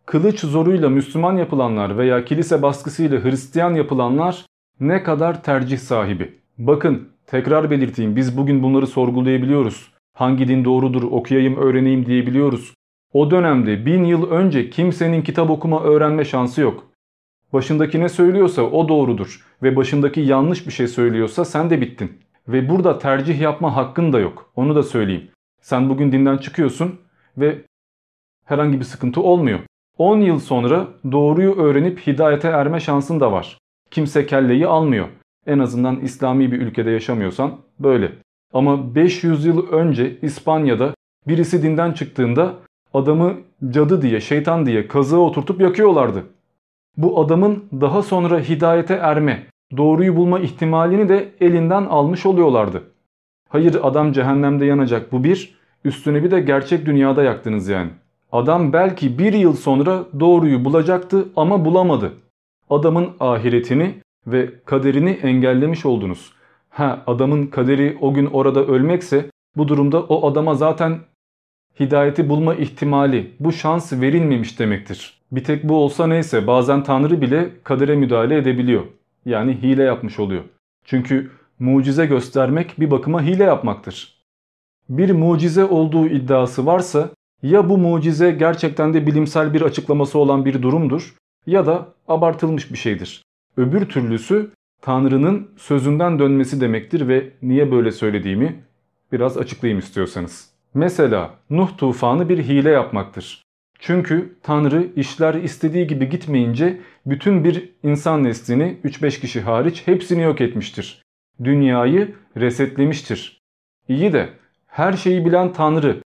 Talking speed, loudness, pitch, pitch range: 130 wpm, -17 LUFS, 145 Hz, 130-165 Hz